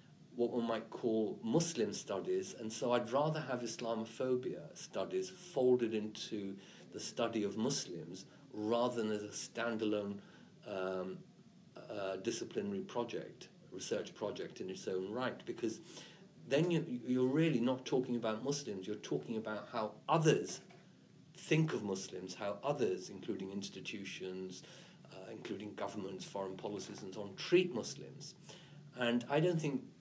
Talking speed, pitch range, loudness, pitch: 140 wpm, 110-155 Hz, -38 LUFS, 120 Hz